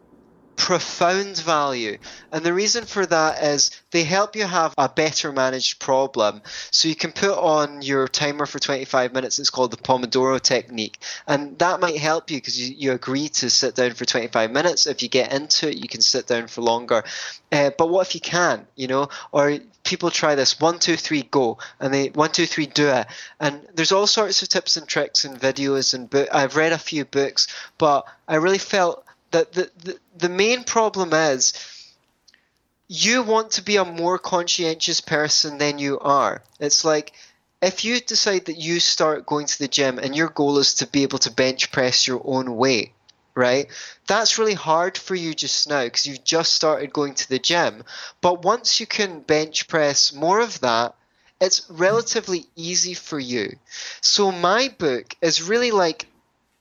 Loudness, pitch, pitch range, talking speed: -20 LUFS, 155 Hz, 135-180 Hz, 190 wpm